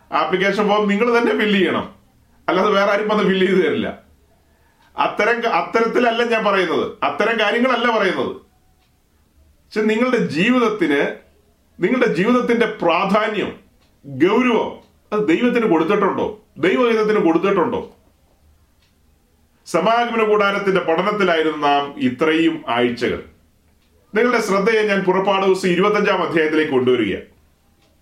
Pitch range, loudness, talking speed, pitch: 140-215 Hz, -17 LUFS, 95 wpm, 195 Hz